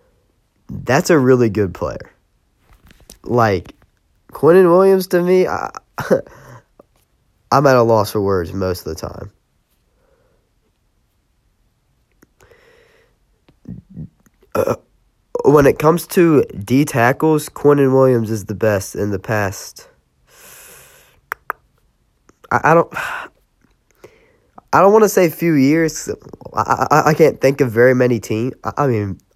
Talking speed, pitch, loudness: 120 wpm, 140 Hz, -15 LUFS